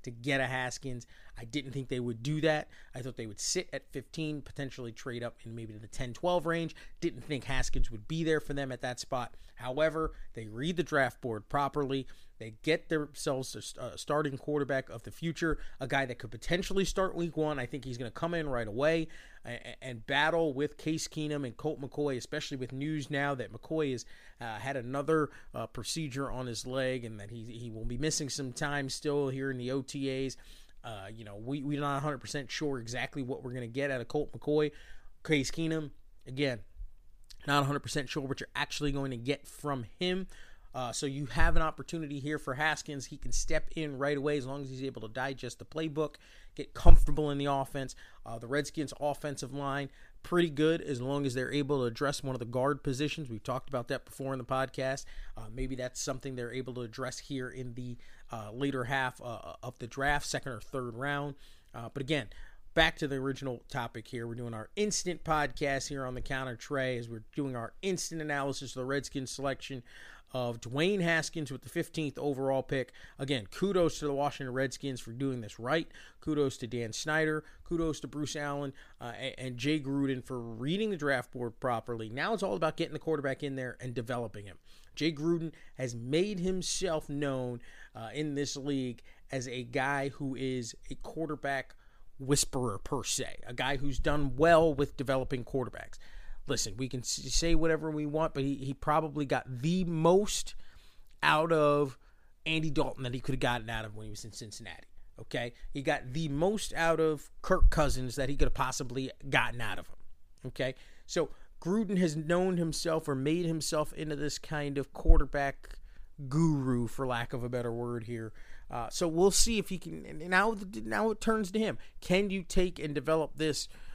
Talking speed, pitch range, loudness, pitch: 200 wpm, 125-155 Hz, -34 LUFS, 140 Hz